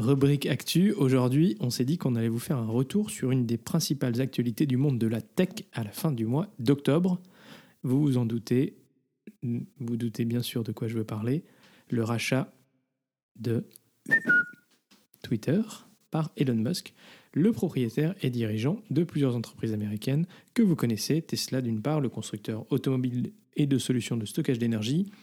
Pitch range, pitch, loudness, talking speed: 120-160 Hz, 130 Hz, -28 LUFS, 170 wpm